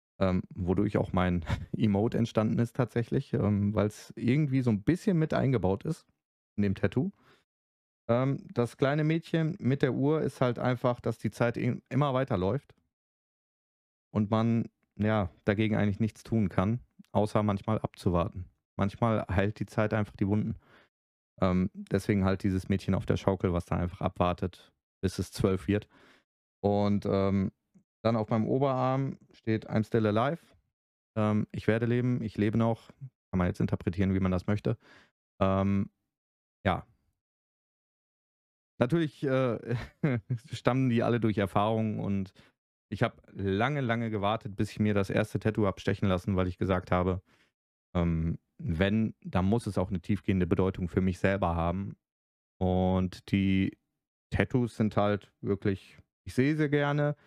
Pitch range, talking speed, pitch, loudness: 95-120 Hz, 155 wpm, 105 Hz, -30 LUFS